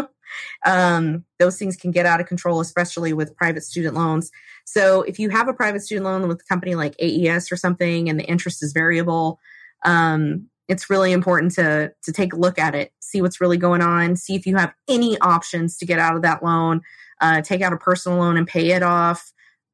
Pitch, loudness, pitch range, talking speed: 175 Hz, -19 LUFS, 165-185 Hz, 215 wpm